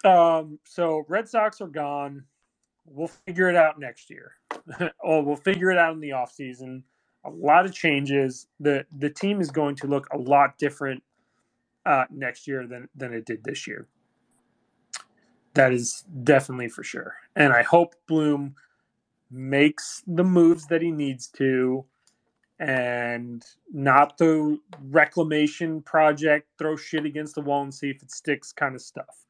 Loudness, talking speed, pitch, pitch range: -23 LUFS, 160 wpm, 145 Hz, 135-165 Hz